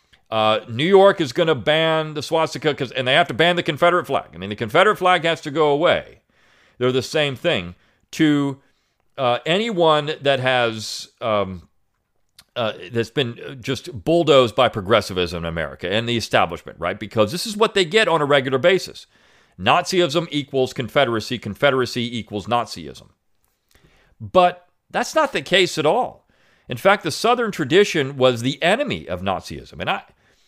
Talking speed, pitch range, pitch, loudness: 165 wpm, 120-175 Hz, 145 Hz, -19 LUFS